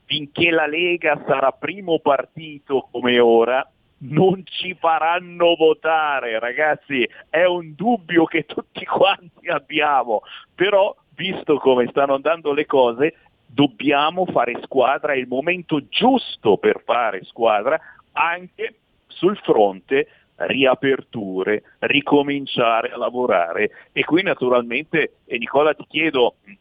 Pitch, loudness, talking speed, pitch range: 150 Hz, -19 LUFS, 115 wpm, 130-175 Hz